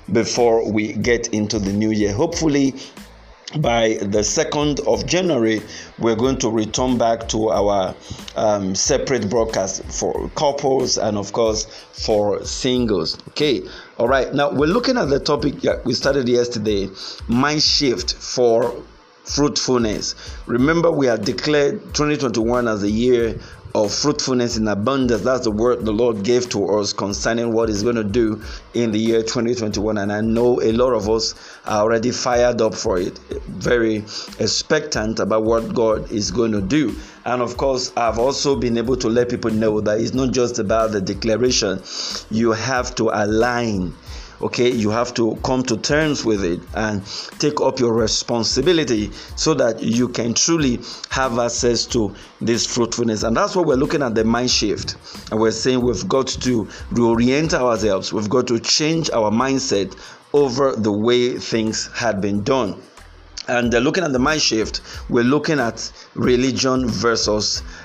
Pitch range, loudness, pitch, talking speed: 110-130 Hz, -19 LUFS, 115 Hz, 165 wpm